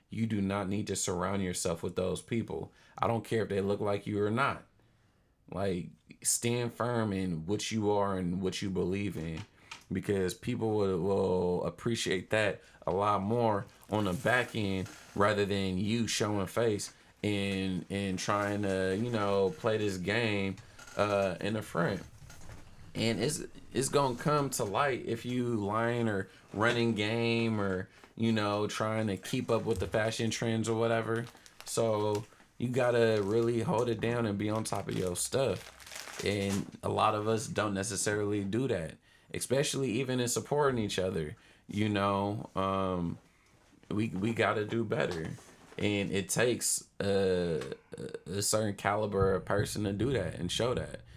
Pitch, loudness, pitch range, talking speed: 105 Hz, -32 LUFS, 100-115 Hz, 165 wpm